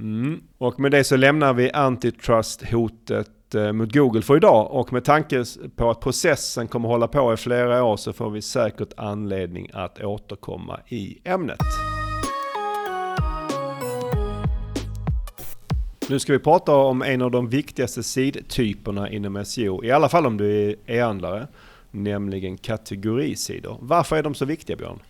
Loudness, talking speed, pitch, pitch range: -22 LUFS, 145 wpm, 120 Hz, 105-140 Hz